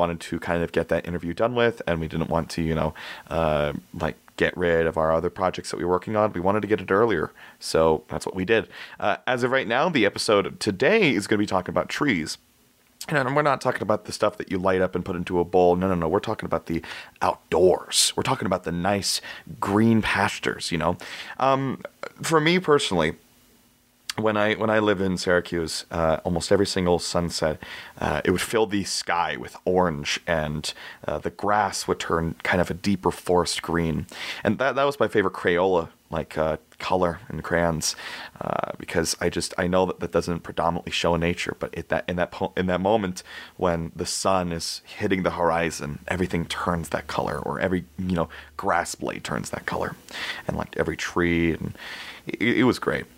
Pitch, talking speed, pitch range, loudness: 90 Hz, 210 wpm, 80-100 Hz, -24 LUFS